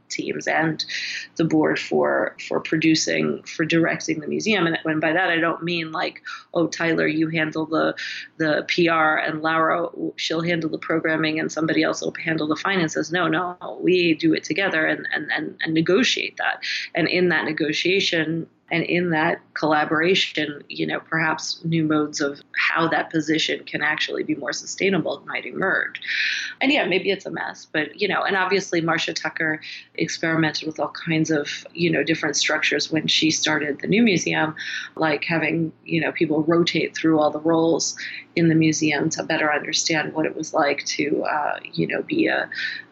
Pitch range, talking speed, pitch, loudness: 155-175 Hz, 180 wpm, 160 Hz, -22 LUFS